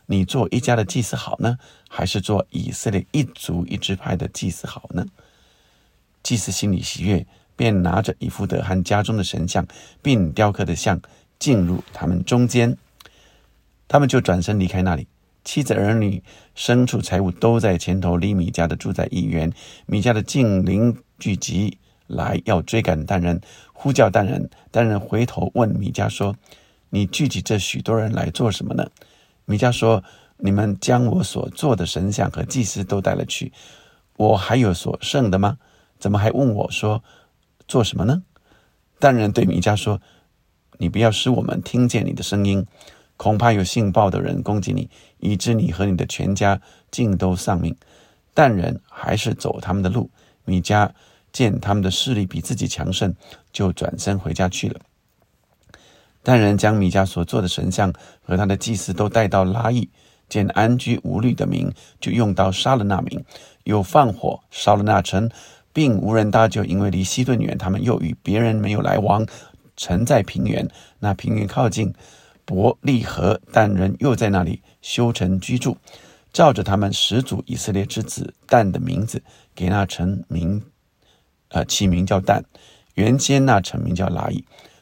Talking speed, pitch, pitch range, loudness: 240 characters per minute, 100 Hz, 95-115 Hz, -20 LUFS